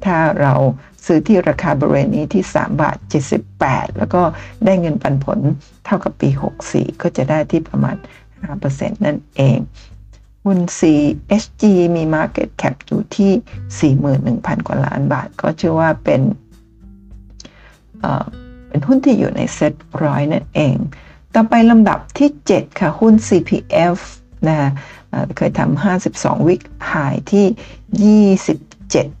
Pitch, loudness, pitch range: 165 Hz, -16 LUFS, 135-200 Hz